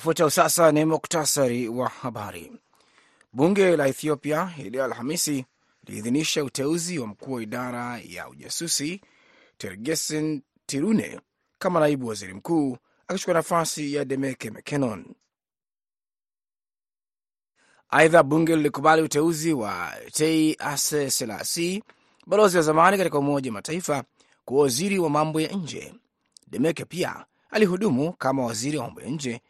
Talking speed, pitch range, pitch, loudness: 120 wpm, 140-175 Hz, 155 Hz, -24 LUFS